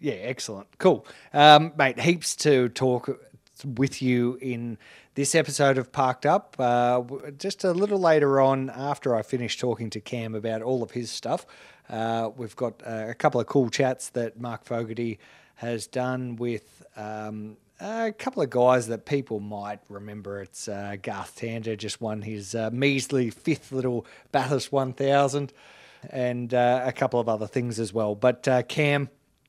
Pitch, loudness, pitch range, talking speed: 125 Hz, -25 LUFS, 115-140 Hz, 170 wpm